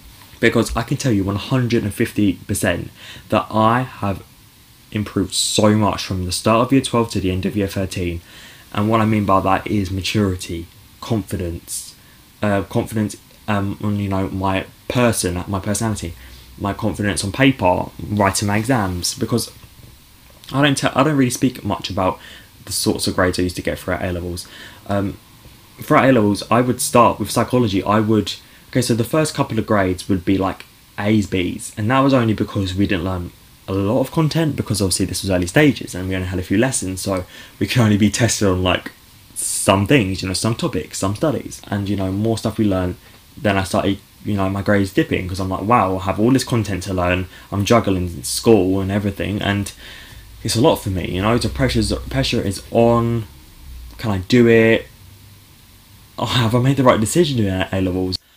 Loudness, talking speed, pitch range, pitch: -19 LUFS, 205 wpm, 95-115 Hz, 105 Hz